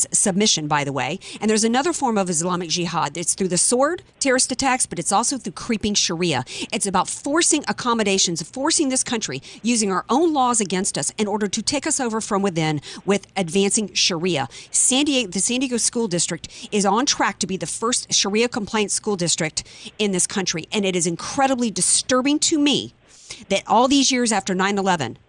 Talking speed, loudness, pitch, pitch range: 190 wpm, -20 LUFS, 210 Hz, 180-250 Hz